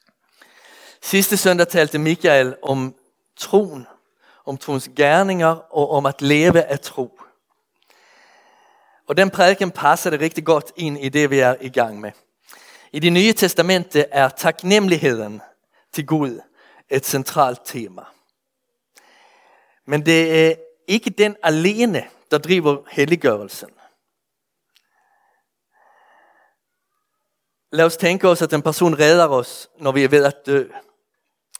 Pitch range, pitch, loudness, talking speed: 145-210 Hz, 165 Hz, -17 LUFS, 125 wpm